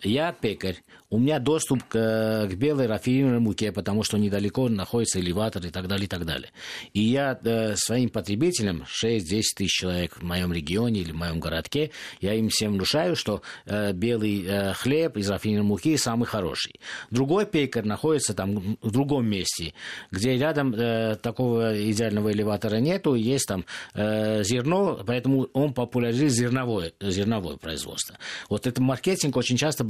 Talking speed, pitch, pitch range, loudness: 160 wpm, 110 Hz, 100-125 Hz, -25 LUFS